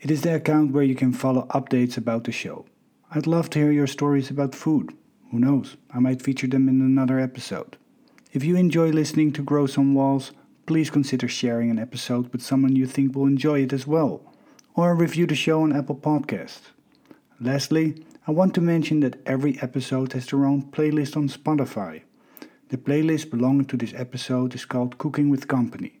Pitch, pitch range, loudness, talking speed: 140 Hz, 130-155 Hz, -23 LUFS, 190 wpm